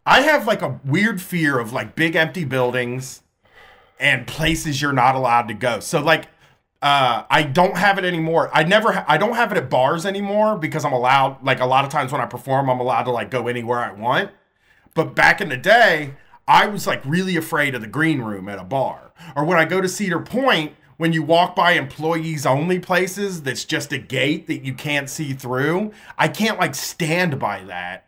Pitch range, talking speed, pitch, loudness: 130-175 Hz, 215 wpm, 155 Hz, -19 LUFS